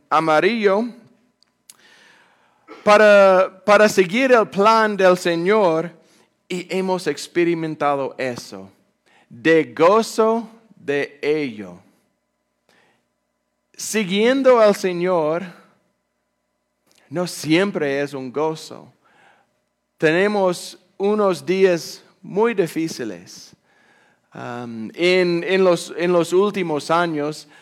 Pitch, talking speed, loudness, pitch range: 180 Hz, 80 wpm, -18 LUFS, 155-200 Hz